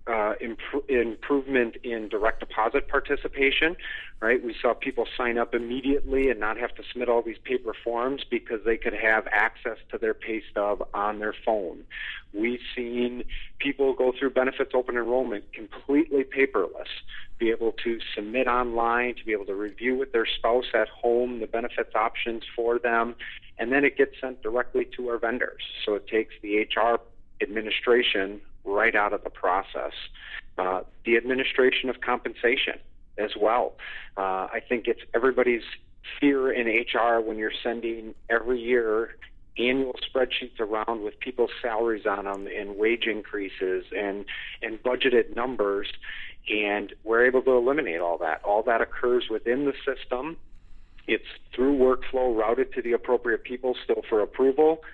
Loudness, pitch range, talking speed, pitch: -26 LUFS, 110-130 Hz, 155 wpm, 120 Hz